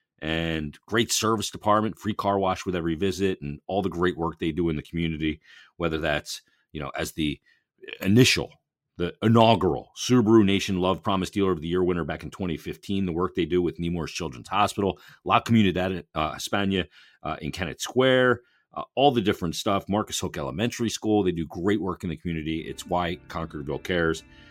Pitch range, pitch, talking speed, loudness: 85-105 Hz, 95 Hz, 190 wpm, -25 LUFS